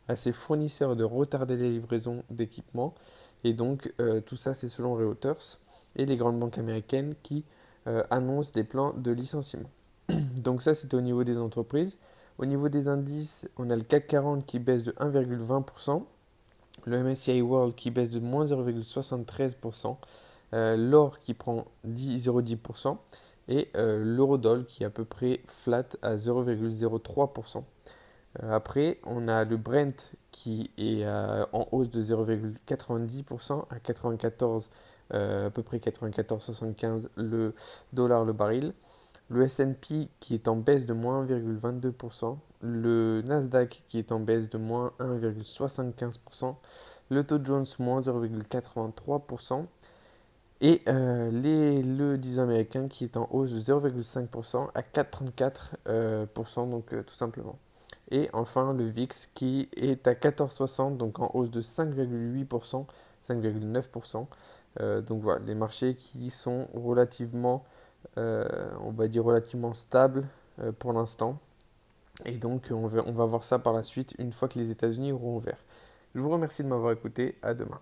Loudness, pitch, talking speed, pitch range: -30 LUFS, 120 Hz, 145 wpm, 115-135 Hz